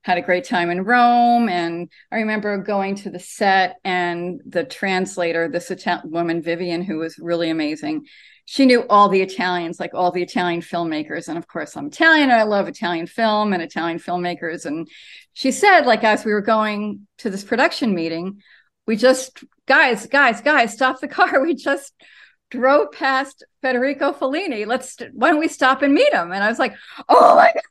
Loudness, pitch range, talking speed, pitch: -18 LUFS, 175-270 Hz, 190 wpm, 215 Hz